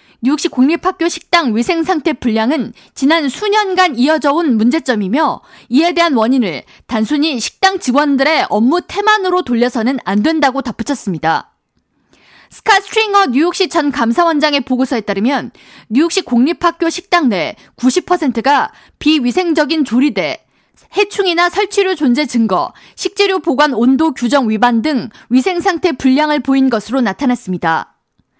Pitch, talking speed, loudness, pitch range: 290 Hz, 315 characters per minute, -14 LUFS, 250-345 Hz